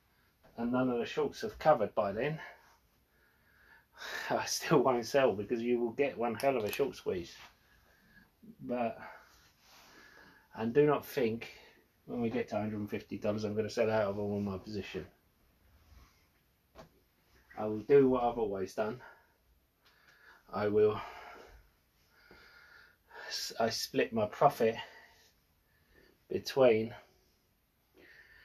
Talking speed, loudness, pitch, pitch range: 120 wpm, -33 LUFS, 110 Hz, 95-120 Hz